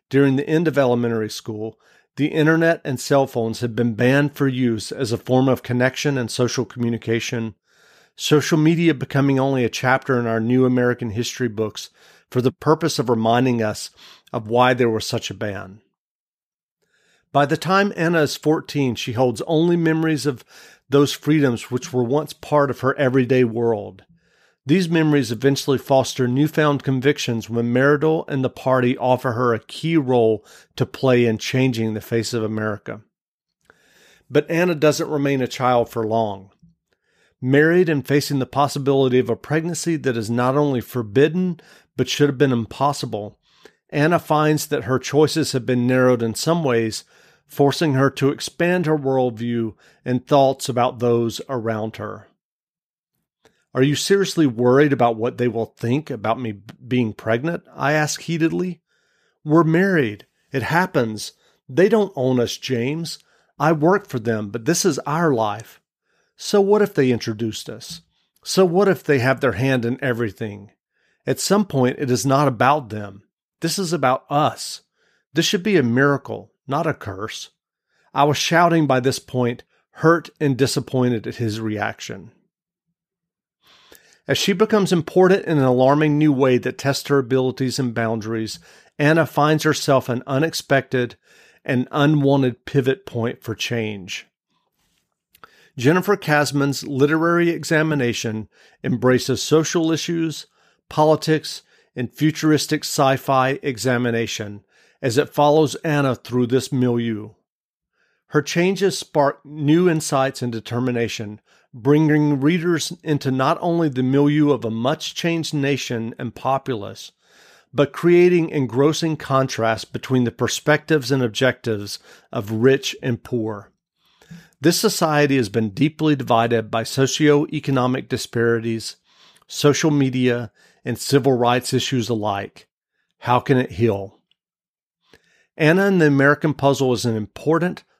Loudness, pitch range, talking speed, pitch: -19 LUFS, 120-155 Hz, 145 wpm, 135 Hz